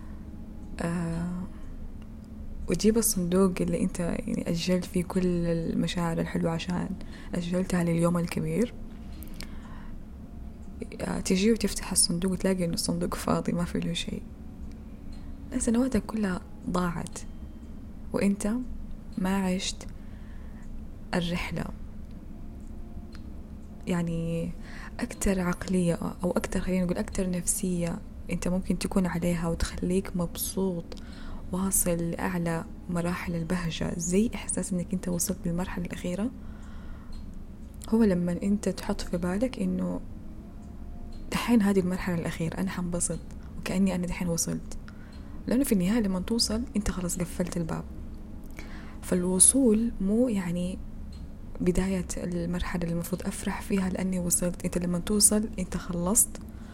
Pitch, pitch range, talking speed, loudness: 180 Hz, 170-195 Hz, 110 wpm, -28 LUFS